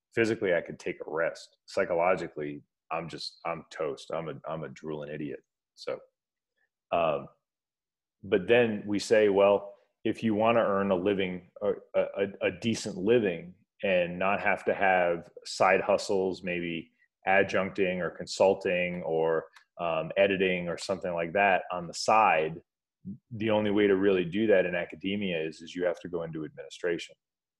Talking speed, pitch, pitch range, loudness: 160 wpm, 100 Hz, 85-110 Hz, -29 LUFS